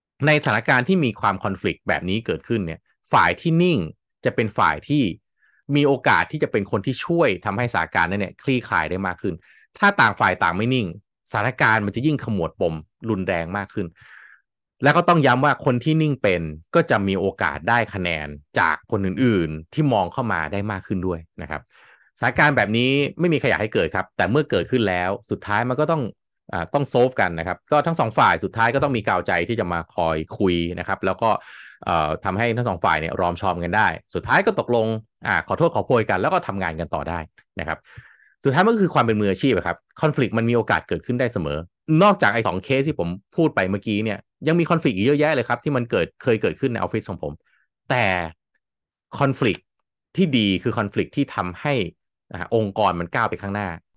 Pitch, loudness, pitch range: 110 Hz, -21 LUFS, 95-140 Hz